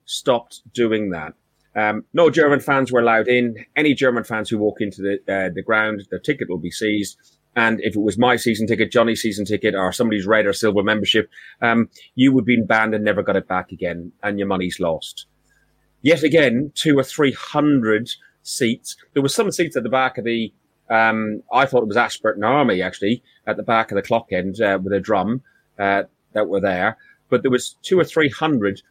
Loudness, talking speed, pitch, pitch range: -19 LUFS, 210 wpm, 110 Hz, 100-125 Hz